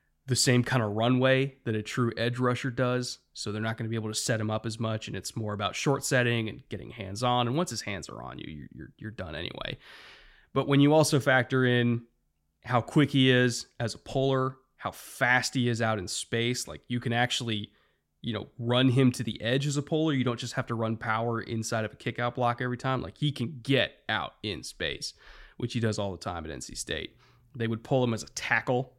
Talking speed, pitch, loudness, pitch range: 240 wpm, 120 Hz, -29 LUFS, 110-130 Hz